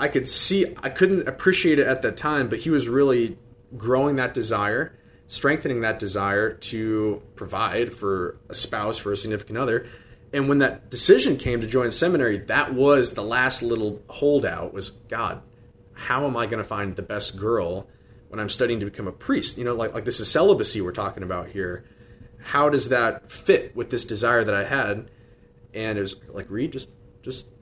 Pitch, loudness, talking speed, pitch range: 120 Hz, -23 LUFS, 195 wpm, 105-130 Hz